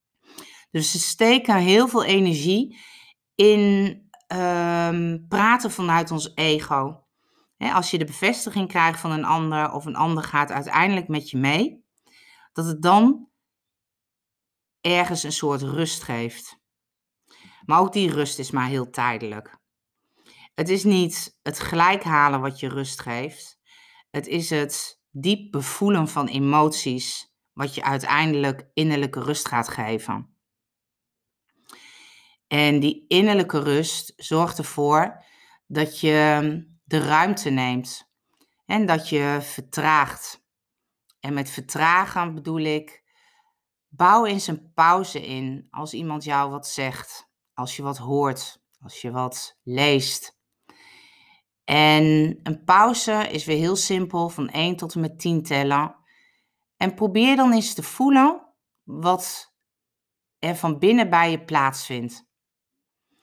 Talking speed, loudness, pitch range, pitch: 125 wpm, -22 LUFS, 140-190 Hz, 155 Hz